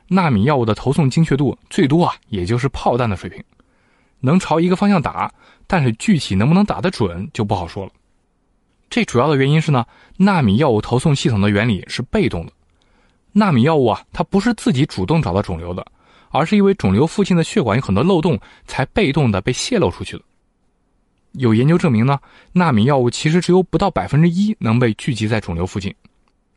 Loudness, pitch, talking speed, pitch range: -17 LUFS, 145 Hz, 310 characters per minute, 115-180 Hz